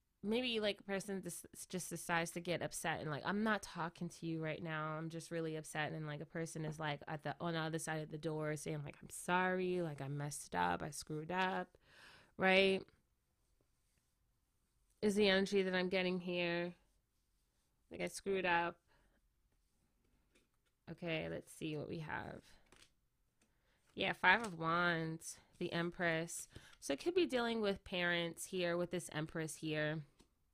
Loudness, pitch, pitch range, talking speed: -40 LUFS, 170 Hz, 155-185 Hz, 165 wpm